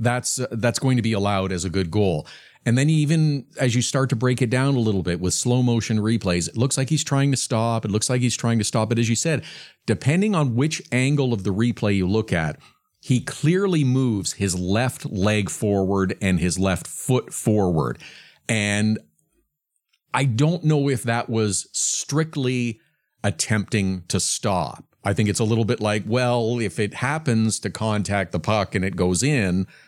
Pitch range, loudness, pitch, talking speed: 100-130 Hz, -22 LUFS, 115 Hz, 195 wpm